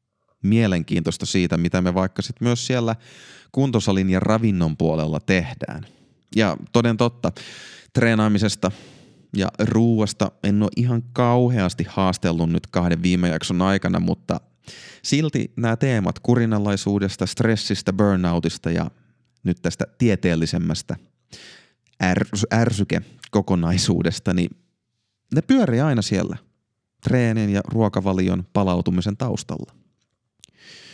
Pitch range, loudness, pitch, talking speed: 90-115 Hz, -21 LUFS, 105 Hz, 100 wpm